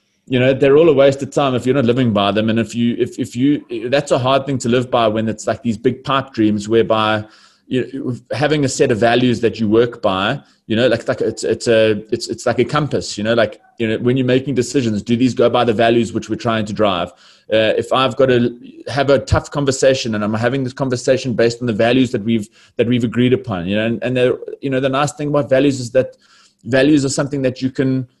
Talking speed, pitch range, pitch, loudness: 255 wpm, 115-135 Hz, 125 Hz, -16 LUFS